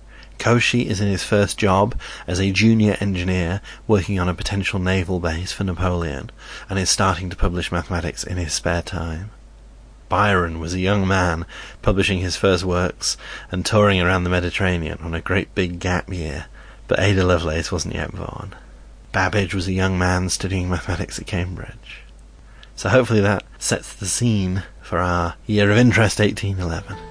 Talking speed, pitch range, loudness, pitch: 165 wpm, 85-100 Hz, -20 LUFS, 95 Hz